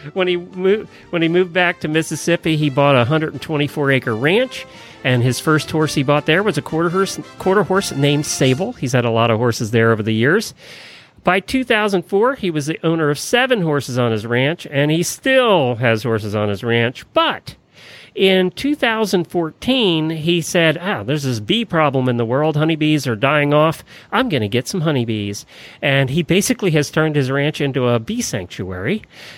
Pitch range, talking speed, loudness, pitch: 130-180 Hz, 195 wpm, -17 LUFS, 155 Hz